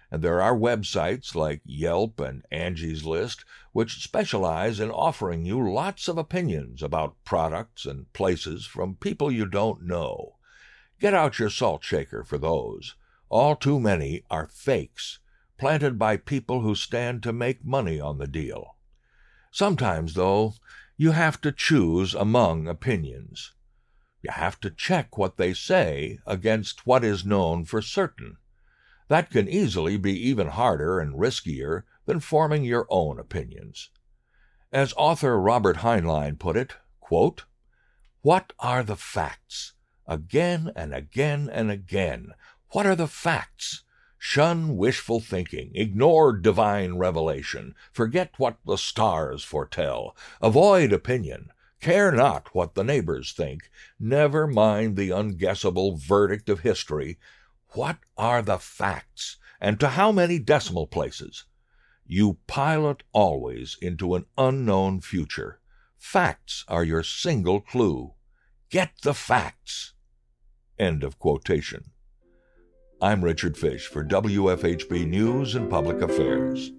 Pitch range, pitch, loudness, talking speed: 85-130 Hz, 105 Hz, -25 LUFS, 130 wpm